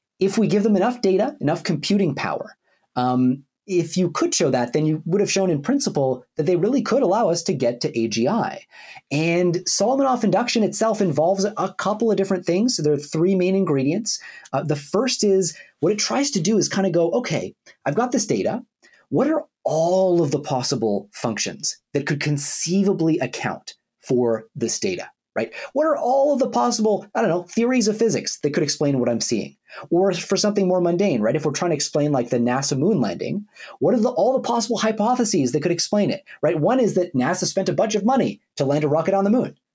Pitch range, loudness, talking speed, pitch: 150-215 Hz, -21 LUFS, 215 wpm, 190 Hz